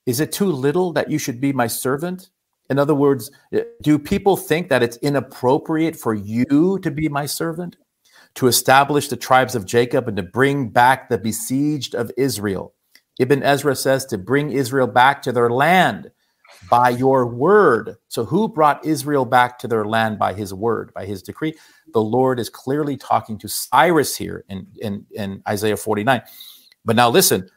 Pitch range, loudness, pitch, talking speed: 115-150 Hz, -18 LUFS, 130 Hz, 180 wpm